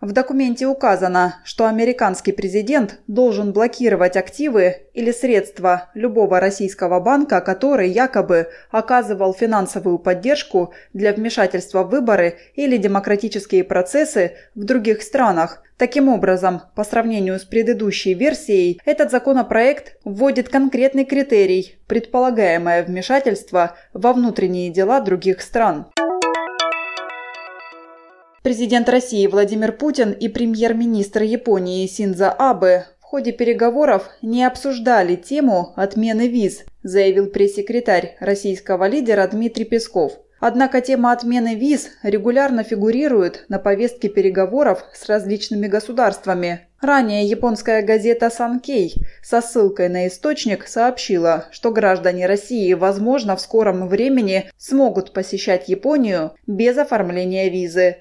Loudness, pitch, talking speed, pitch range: -18 LUFS, 210 Hz, 110 wpm, 190-245 Hz